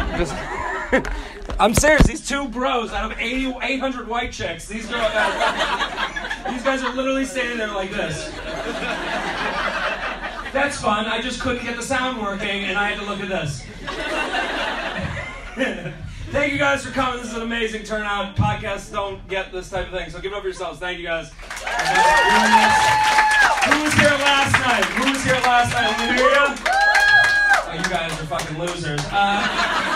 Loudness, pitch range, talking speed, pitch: -20 LUFS, 200-275 Hz, 165 wpm, 235 Hz